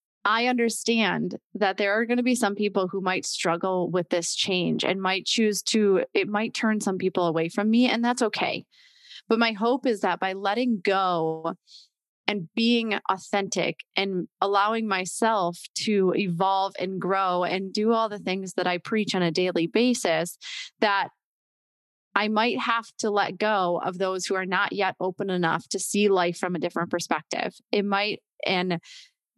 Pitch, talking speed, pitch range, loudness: 195 Hz, 175 wpm, 185-220 Hz, -25 LUFS